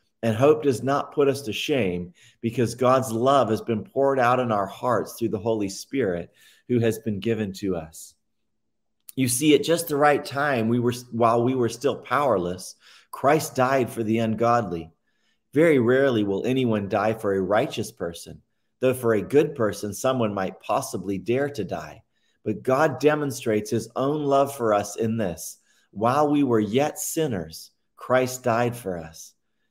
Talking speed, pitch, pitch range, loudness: 175 wpm, 115 Hz, 105-130 Hz, -24 LUFS